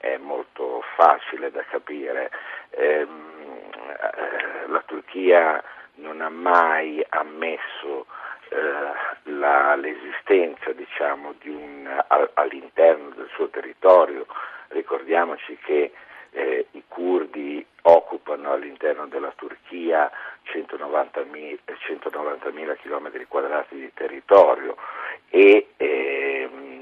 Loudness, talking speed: -22 LUFS, 85 wpm